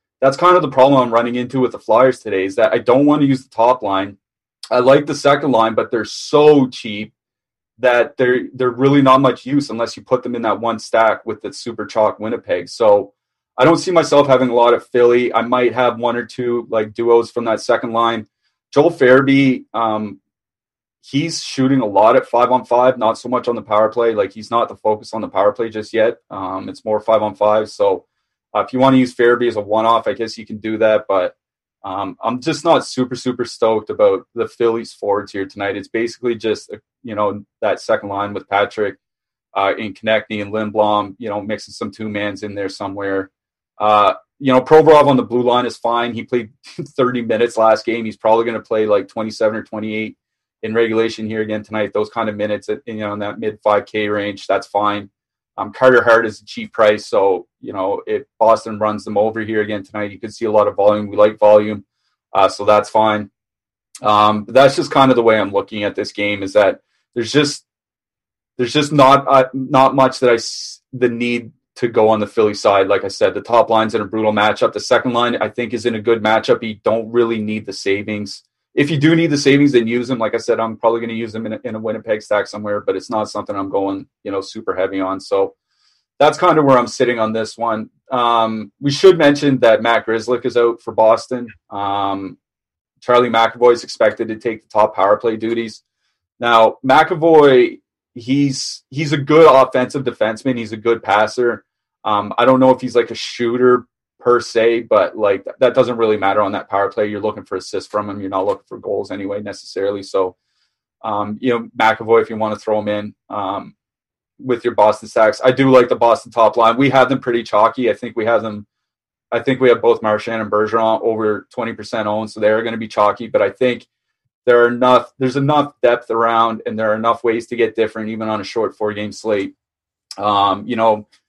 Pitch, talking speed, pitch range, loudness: 115 Hz, 225 wpm, 105-130 Hz, -16 LUFS